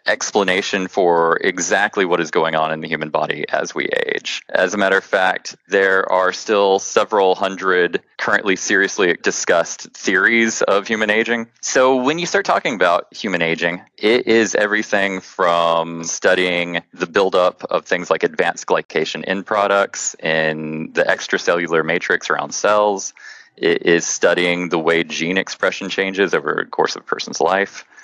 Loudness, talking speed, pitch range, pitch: -17 LUFS, 160 wpm, 85-100 Hz, 95 Hz